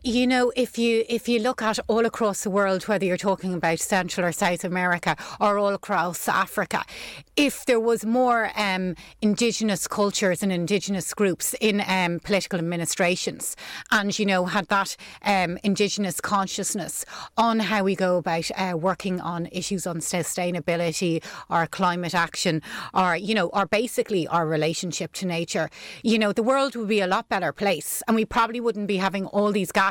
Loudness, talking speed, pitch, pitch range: -24 LUFS, 175 wpm, 195 Hz, 175-215 Hz